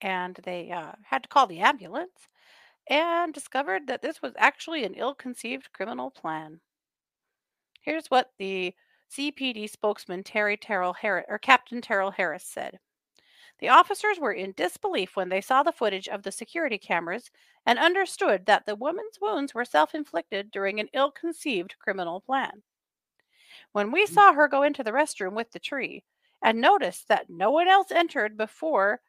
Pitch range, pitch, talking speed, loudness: 195-310 Hz, 240 Hz, 165 wpm, -26 LUFS